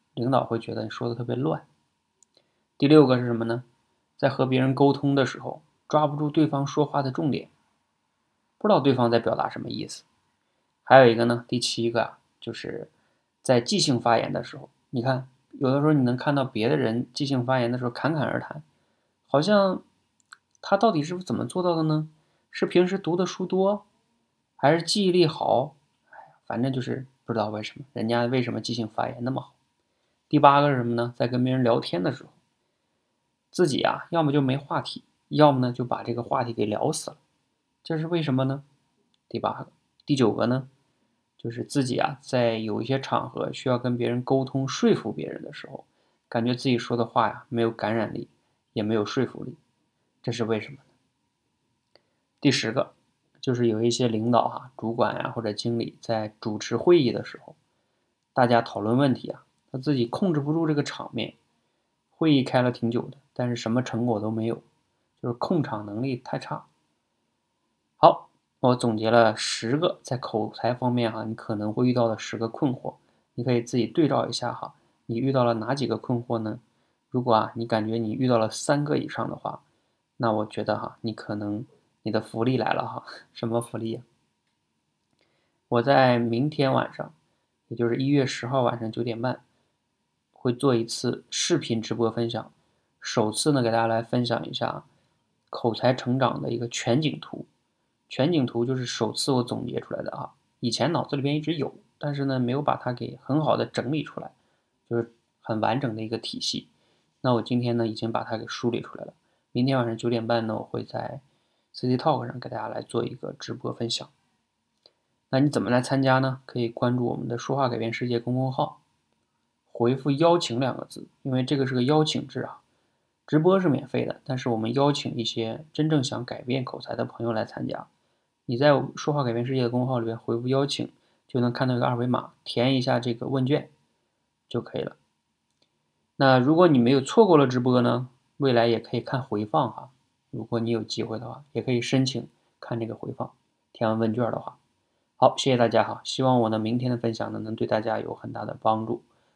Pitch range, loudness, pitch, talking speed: 115-135 Hz, -25 LUFS, 125 Hz, 285 characters per minute